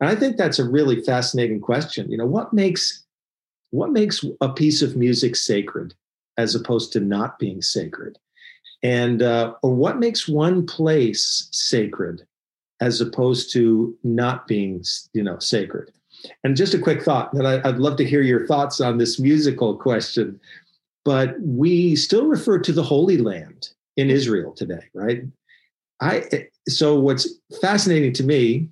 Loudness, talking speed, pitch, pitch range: -20 LUFS, 155 wpm, 135 Hz, 120-155 Hz